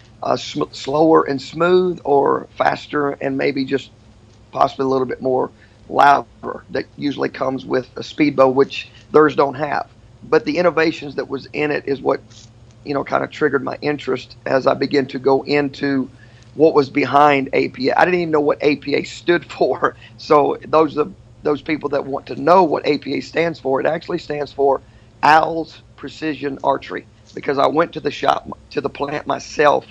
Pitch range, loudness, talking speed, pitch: 130-150 Hz, -18 LUFS, 185 wpm, 140 Hz